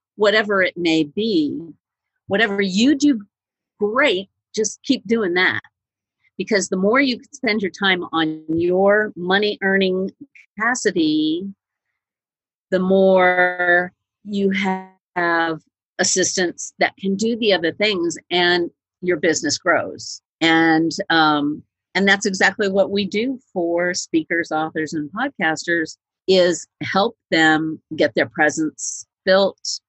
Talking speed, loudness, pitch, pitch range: 115 wpm, -19 LUFS, 190 Hz, 165-210 Hz